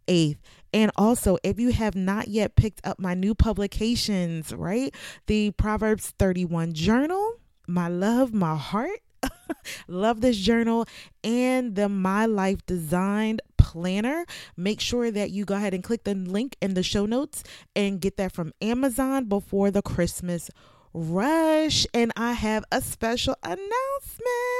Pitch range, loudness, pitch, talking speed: 185-235 Hz, -25 LUFS, 205 Hz, 145 wpm